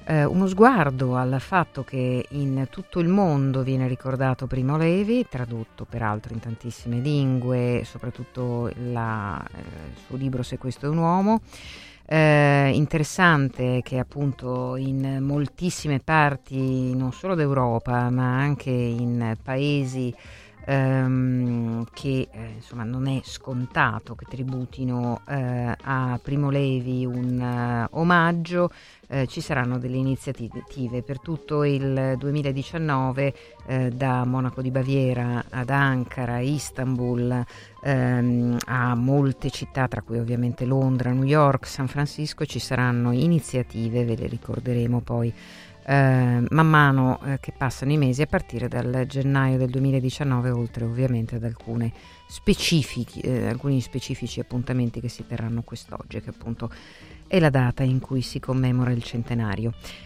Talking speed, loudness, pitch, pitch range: 130 wpm, -24 LUFS, 130 Hz, 120-140 Hz